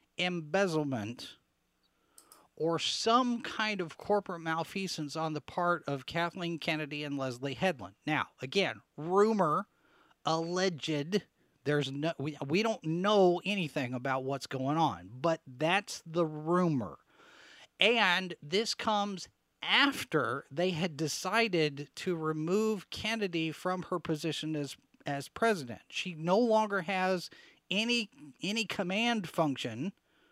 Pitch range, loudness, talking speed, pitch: 150-195 Hz, -32 LUFS, 115 wpm, 170 Hz